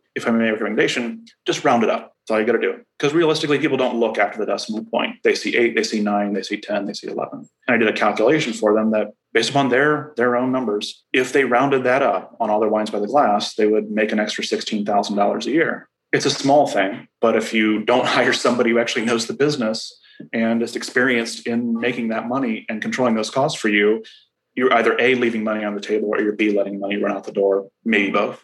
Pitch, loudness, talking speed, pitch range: 115 Hz, -19 LUFS, 245 wpm, 105-125 Hz